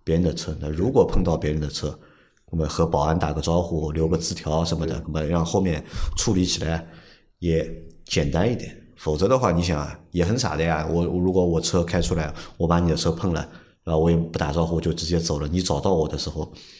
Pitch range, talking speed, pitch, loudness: 80-90 Hz, 325 characters per minute, 85 Hz, -23 LUFS